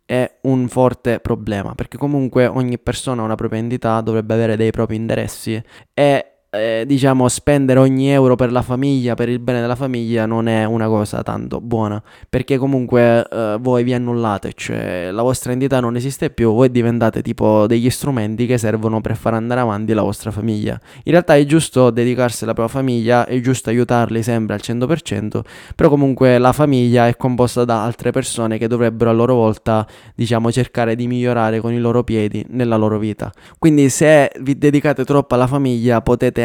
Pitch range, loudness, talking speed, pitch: 115-130 Hz, -16 LUFS, 185 wpm, 120 Hz